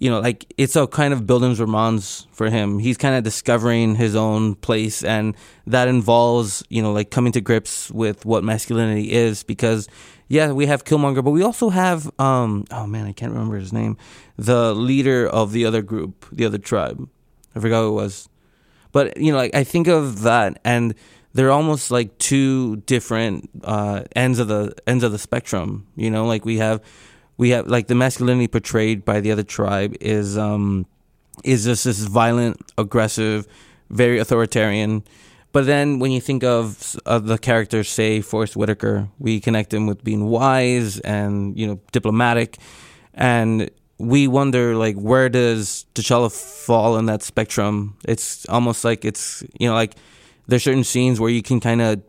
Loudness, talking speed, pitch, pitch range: -19 LUFS, 180 wpm, 115 Hz, 105-125 Hz